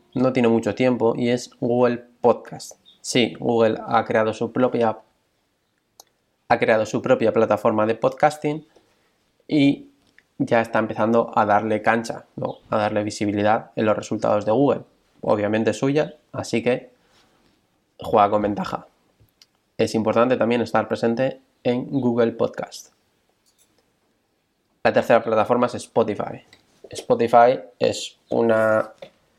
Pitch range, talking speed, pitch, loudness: 110-125 Hz, 125 wpm, 115 Hz, -21 LUFS